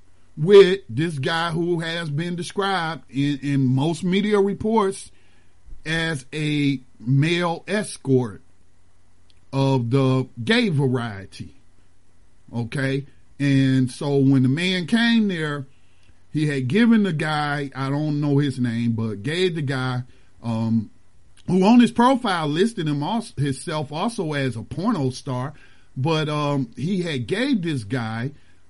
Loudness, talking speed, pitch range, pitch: -22 LUFS, 130 wpm, 120-170 Hz, 140 Hz